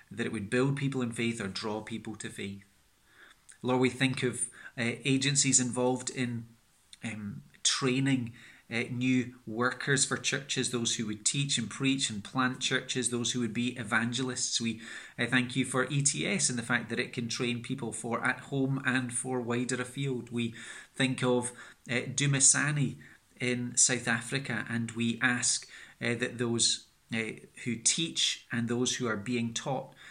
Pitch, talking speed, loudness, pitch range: 125 Hz, 170 wpm, -30 LUFS, 115-130 Hz